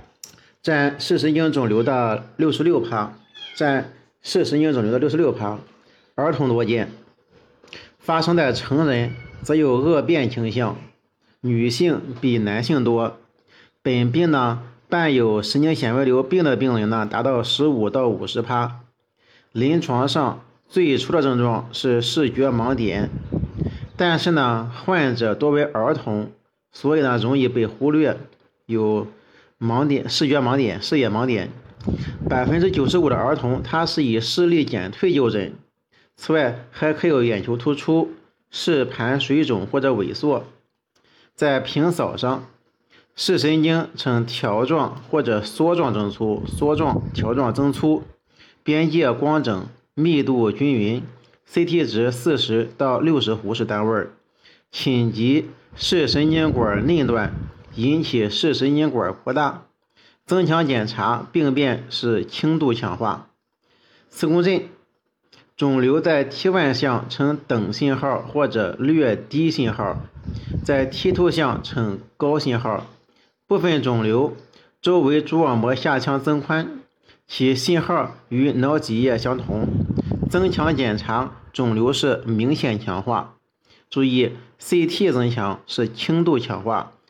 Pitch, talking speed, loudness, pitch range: 130 Hz, 195 characters per minute, -21 LUFS, 115-155 Hz